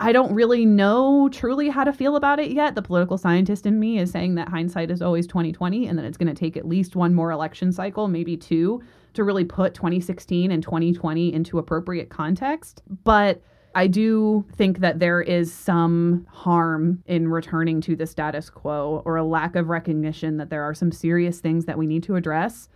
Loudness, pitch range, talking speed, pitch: -22 LUFS, 165-200 Hz, 205 wpm, 175 Hz